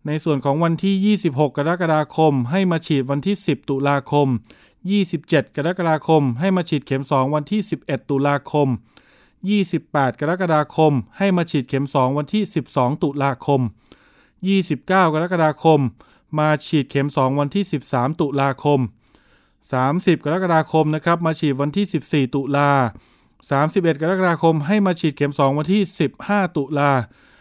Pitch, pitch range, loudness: 150 Hz, 140-170 Hz, -19 LUFS